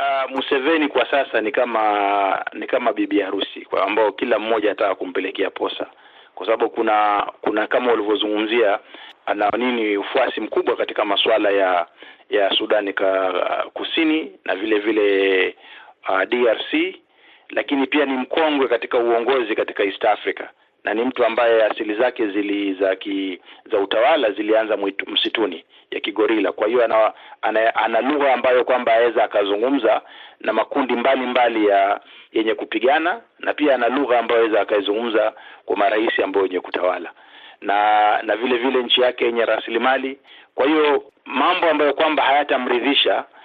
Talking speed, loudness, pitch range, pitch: 140 wpm, -19 LUFS, 105-140 Hz, 120 Hz